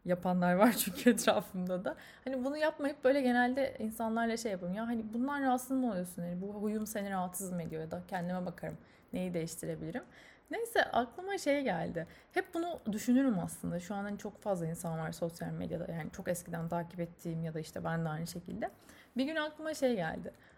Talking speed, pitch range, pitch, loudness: 190 wpm, 175-255 Hz, 205 Hz, -35 LUFS